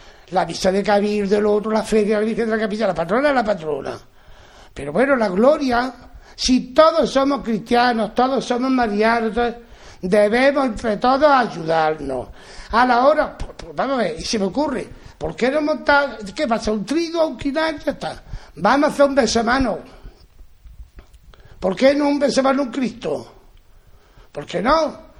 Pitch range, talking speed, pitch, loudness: 210-275 Hz, 170 wpm, 240 Hz, -18 LUFS